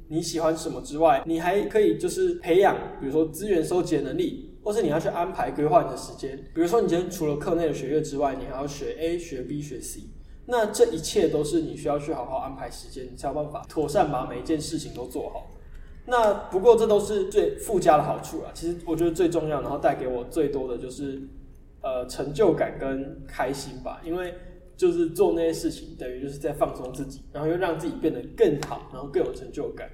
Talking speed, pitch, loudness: 335 characters per minute, 165 Hz, -26 LUFS